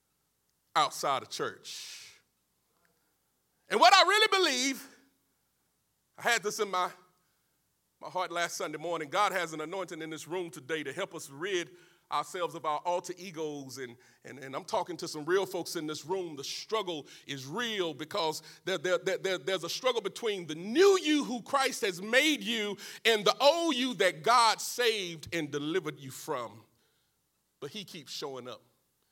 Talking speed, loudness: 175 wpm, -30 LUFS